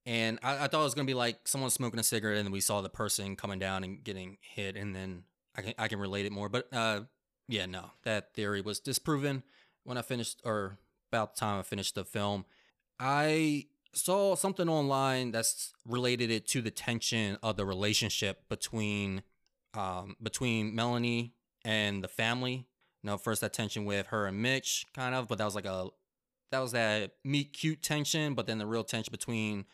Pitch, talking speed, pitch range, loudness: 115 Hz, 200 wpm, 100-125 Hz, -33 LUFS